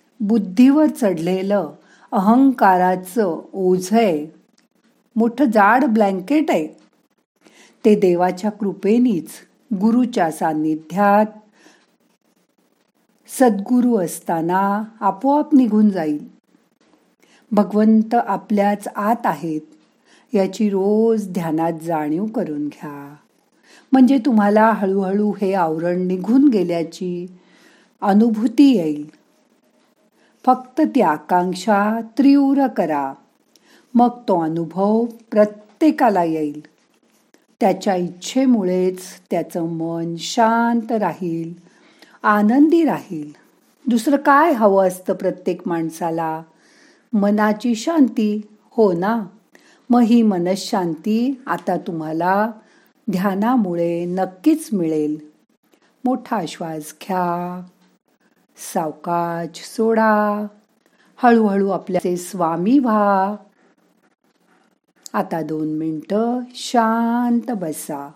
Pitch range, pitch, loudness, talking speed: 175-235 Hz, 205 Hz, -18 LUFS, 75 wpm